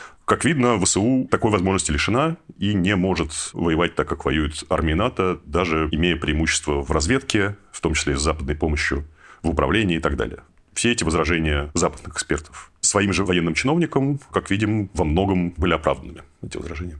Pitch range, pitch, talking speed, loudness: 80-100 Hz, 90 Hz, 170 wpm, -21 LUFS